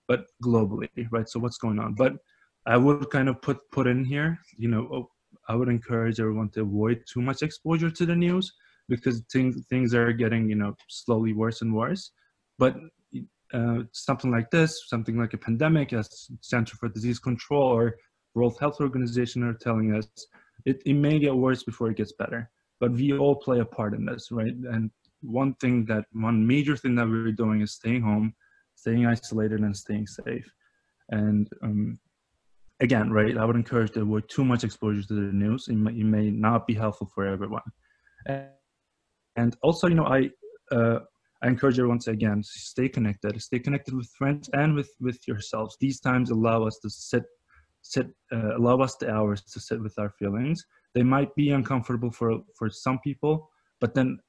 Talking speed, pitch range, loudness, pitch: 190 wpm, 110-130 Hz, -26 LUFS, 120 Hz